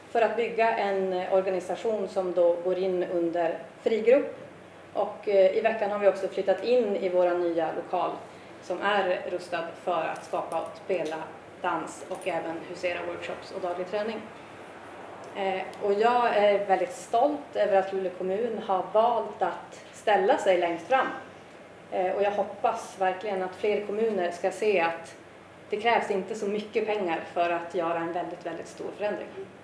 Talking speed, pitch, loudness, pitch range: 160 wpm, 190 Hz, -28 LUFS, 180-210 Hz